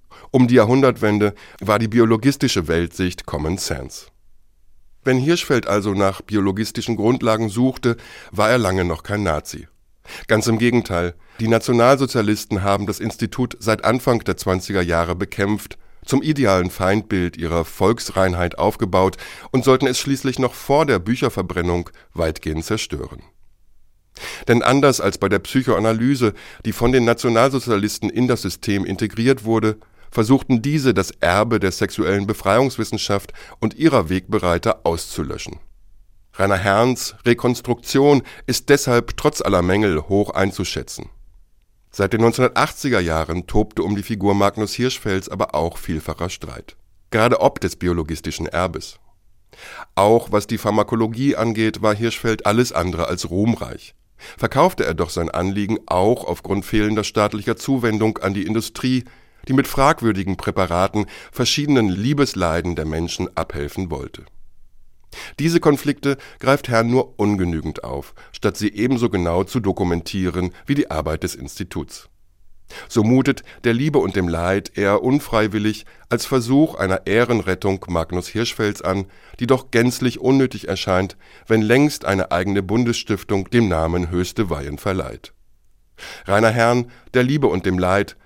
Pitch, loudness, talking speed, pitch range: 105 Hz, -19 LUFS, 135 wpm, 90-120 Hz